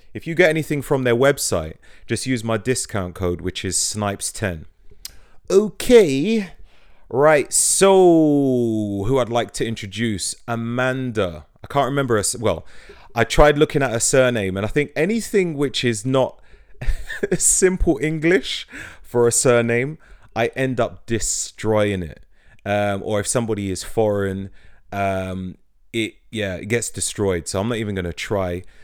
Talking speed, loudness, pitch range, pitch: 145 wpm, -20 LUFS, 100-135 Hz, 115 Hz